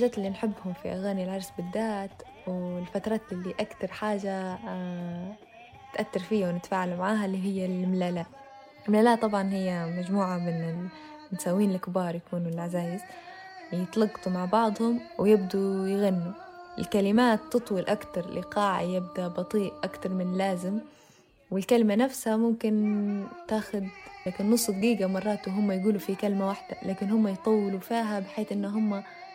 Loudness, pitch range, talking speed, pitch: -29 LUFS, 185-220 Hz, 125 wpm, 200 Hz